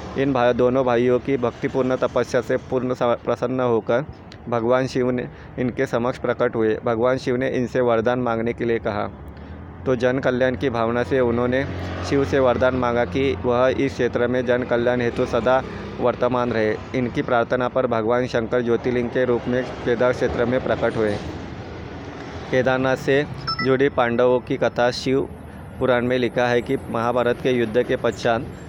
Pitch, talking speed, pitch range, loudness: 125 Hz, 165 wpm, 115-130 Hz, -21 LUFS